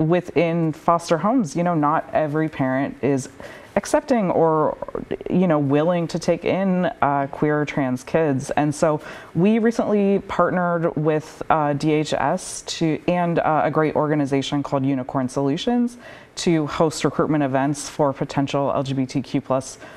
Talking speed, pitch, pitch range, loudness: 140 wpm, 155 Hz, 140-175 Hz, -21 LUFS